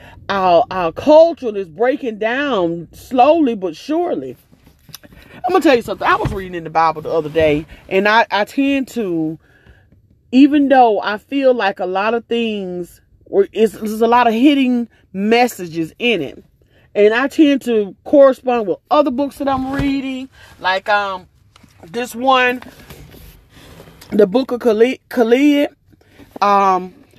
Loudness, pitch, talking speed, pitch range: -15 LUFS, 235 Hz, 150 wpm, 195-270 Hz